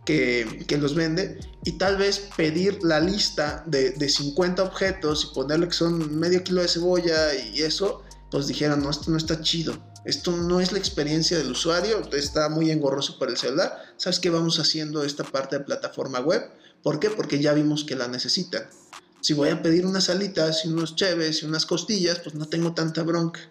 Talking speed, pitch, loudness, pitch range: 200 wpm, 160 Hz, -24 LUFS, 150-175 Hz